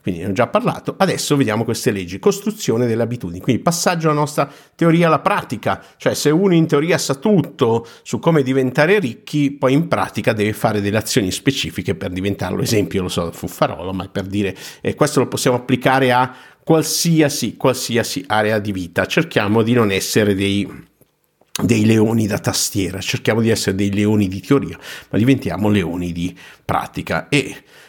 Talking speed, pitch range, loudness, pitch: 170 wpm, 100-145 Hz, -18 LUFS, 120 Hz